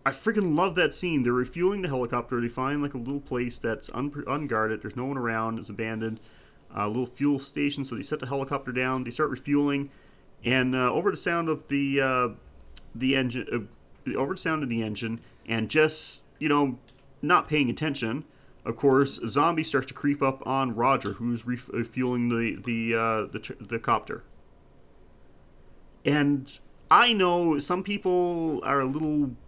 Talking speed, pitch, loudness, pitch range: 180 wpm, 130 Hz, -27 LUFS, 115-145 Hz